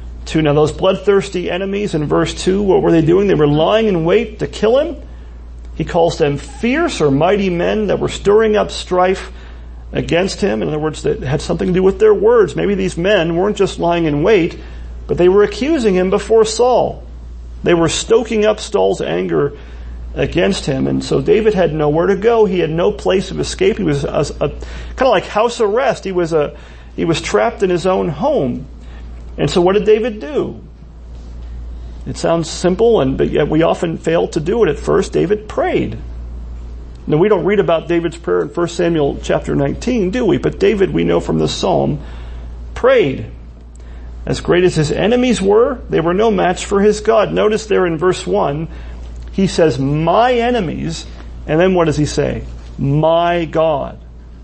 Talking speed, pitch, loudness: 190 wpm, 165 Hz, -15 LUFS